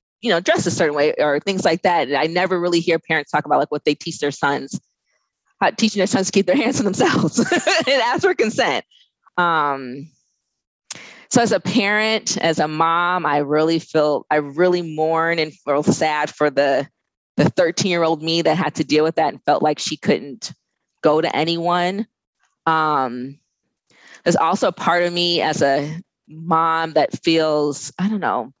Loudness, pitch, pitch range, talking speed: -19 LUFS, 160 Hz, 150-175 Hz, 190 wpm